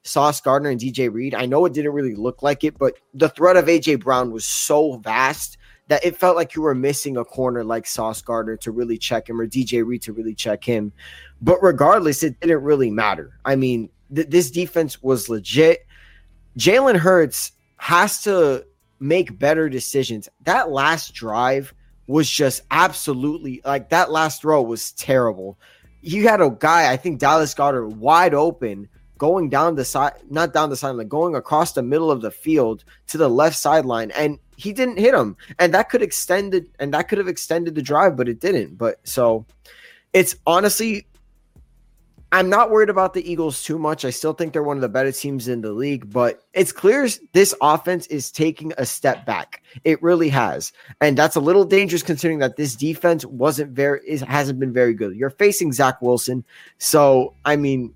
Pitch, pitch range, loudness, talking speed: 145 Hz, 125-165 Hz, -19 LUFS, 195 wpm